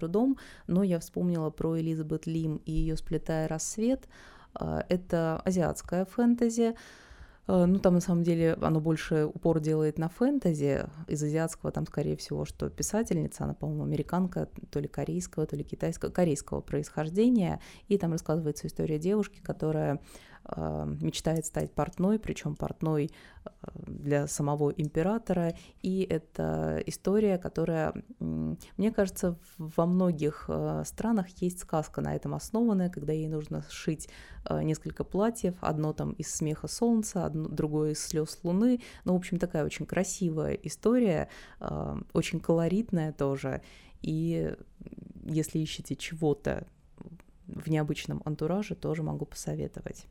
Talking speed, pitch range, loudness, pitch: 125 wpm, 150-185 Hz, -31 LUFS, 160 Hz